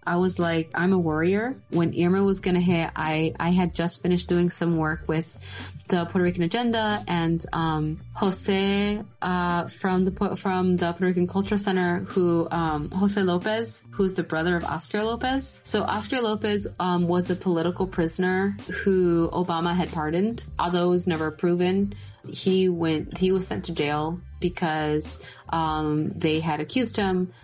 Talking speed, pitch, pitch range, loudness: 165 wpm, 175 Hz, 165-190 Hz, -25 LUFS